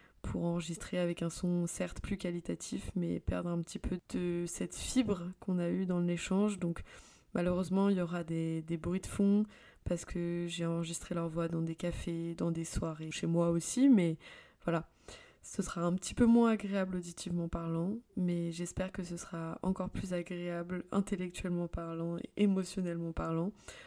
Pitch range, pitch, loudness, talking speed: 170-185 Hz, 175 Hz, -35 LUFS, 175 wpm